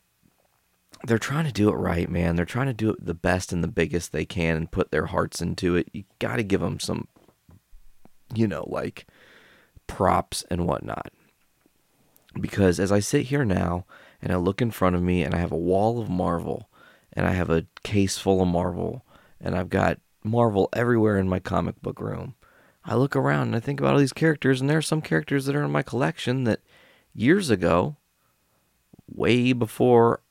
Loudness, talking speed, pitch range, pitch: -24 LUFS, 200 wpm, 85-120 Hz, 100 Hz